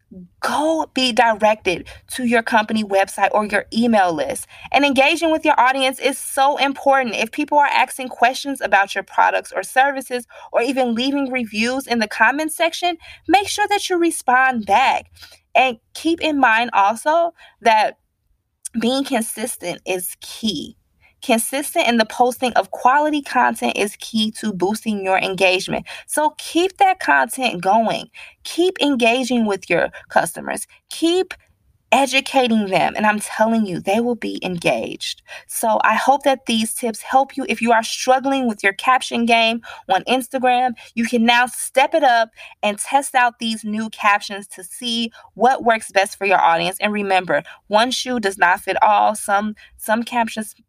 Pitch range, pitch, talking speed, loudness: 210-270 Hz, 235 Hz, 160 wpm, -18 LUFS